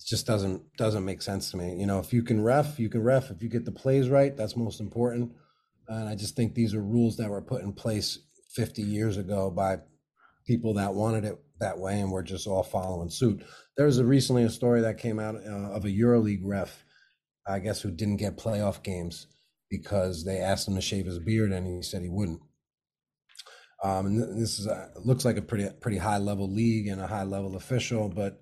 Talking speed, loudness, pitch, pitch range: 220 wpm, -29 LUFS, 105 Hz, 95-115 Hz